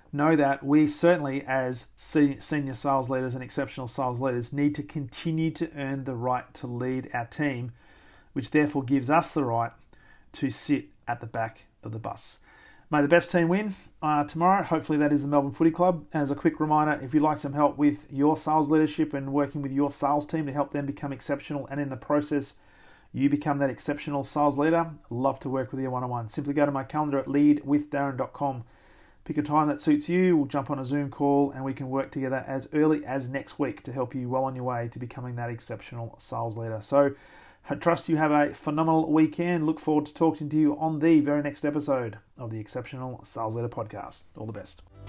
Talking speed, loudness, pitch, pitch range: 215 wpm, -27 LUFS, 140 Hz, 130-150 Hz